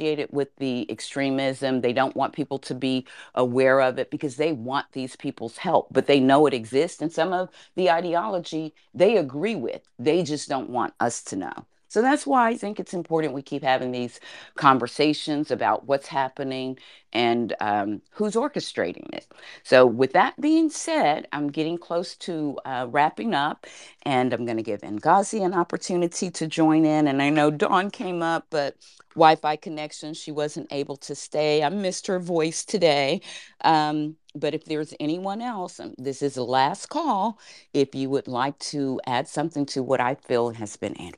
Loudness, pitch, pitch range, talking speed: -24 LUFS, 150 Hz, 135-170 Hz, 185 wpm